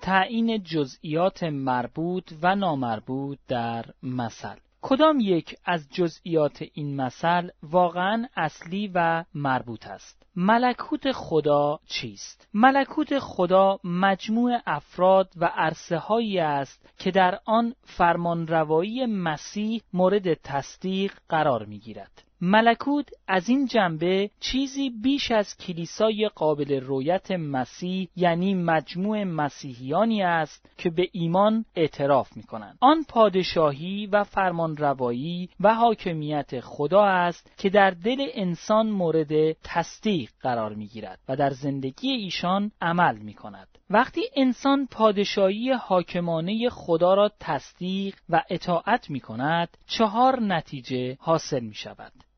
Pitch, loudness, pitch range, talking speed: 180 Hz, -24 LUFS, 150-210 Hz, 115 wpm